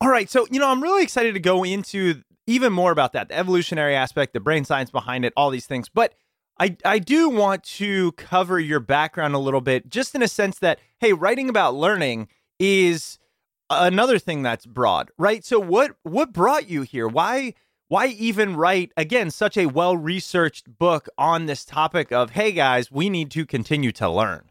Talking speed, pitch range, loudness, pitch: 195 wpm, 145-210 Hz, -21 LUFS, 175 Hz